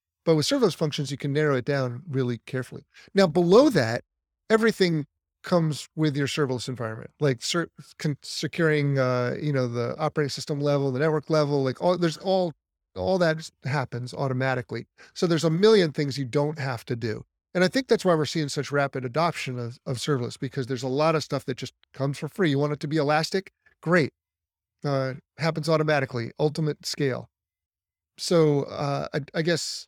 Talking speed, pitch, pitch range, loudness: 185 wpm, 145 Hz, 130-160 Hz, -25 LUFS